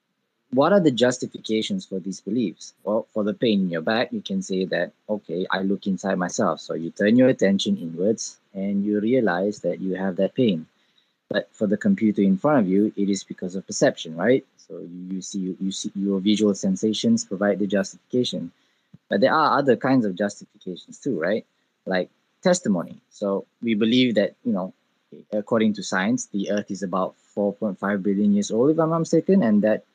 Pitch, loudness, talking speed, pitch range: 105 Hz, -23 LUFS, 190 wpm, 95-120 Hz